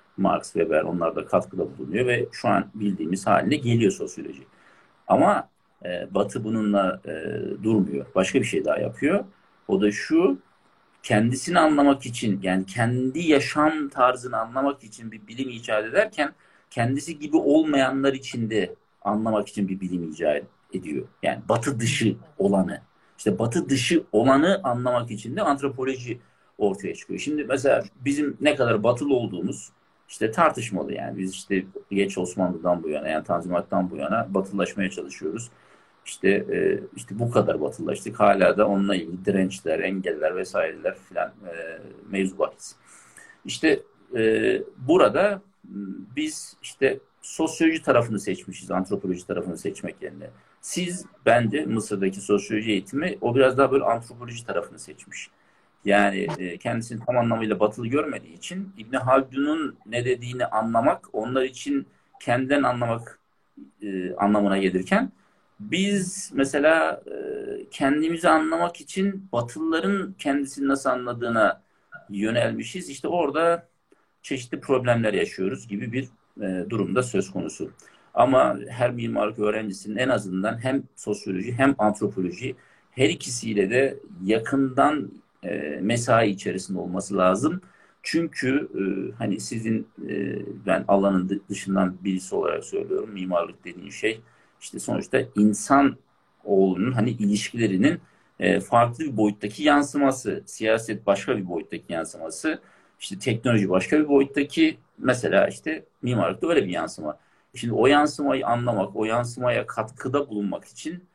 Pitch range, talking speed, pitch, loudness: 100-145 Hz, 125 wpm, 120 Hz, -24 LUFS